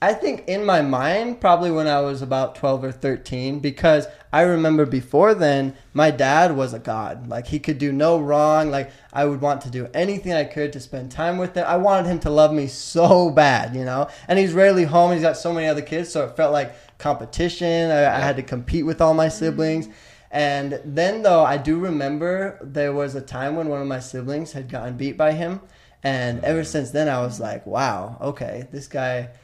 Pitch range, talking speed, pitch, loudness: 135-165 Hz, 220 wpm, 150 Hz, -20 LUFS